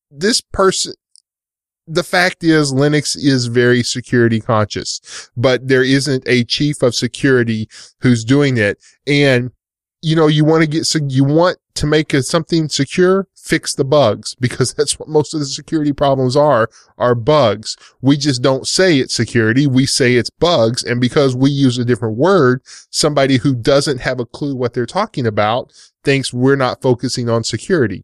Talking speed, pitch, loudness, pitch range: 175 wpm, 135 Hz, -15 LUFS, 125-150 Hz